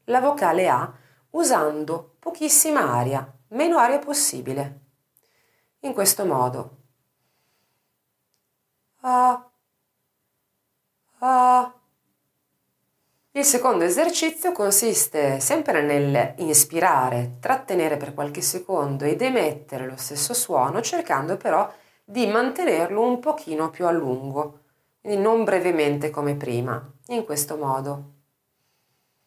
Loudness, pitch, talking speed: -22 LUFS, 165 Hz, 90 wpm